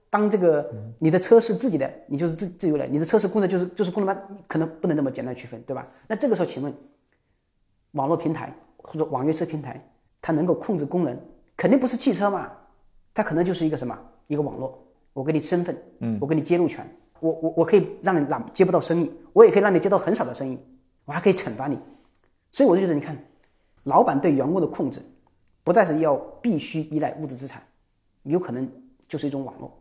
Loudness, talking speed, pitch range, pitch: -23 LUFS, 340 characters per minute, 135-190 Hz, 160 Hz